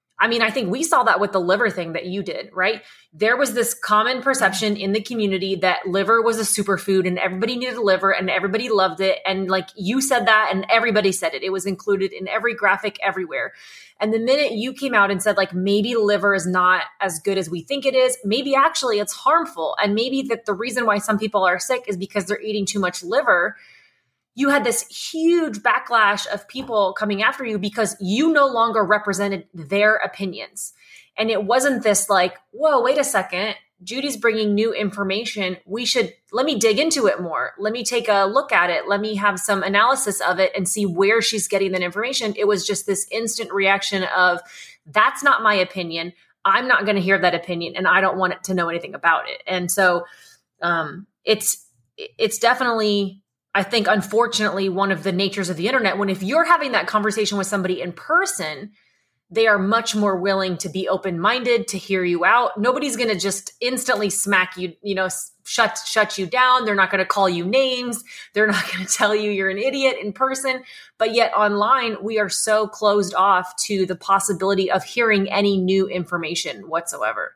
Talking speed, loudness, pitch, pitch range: 205 wpm, -20 LUFS, 205 Hz, 190-230 Hz